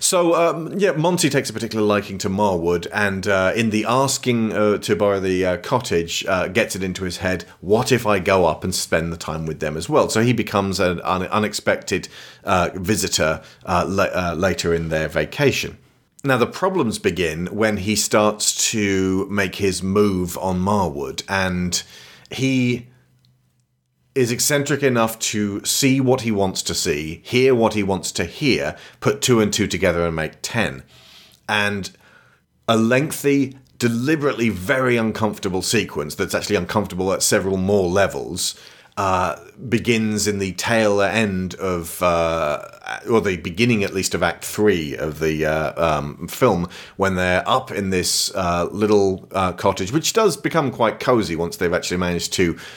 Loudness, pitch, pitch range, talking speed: -20 LUFS, 105 Hz, 90-120 Hz, 165 wpm